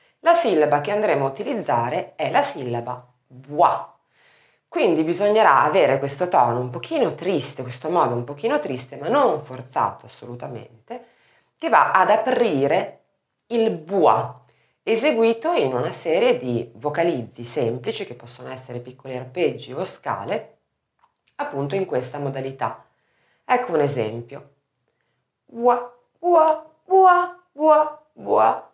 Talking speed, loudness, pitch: 125 wpm, -21 LUFS, 150 Hz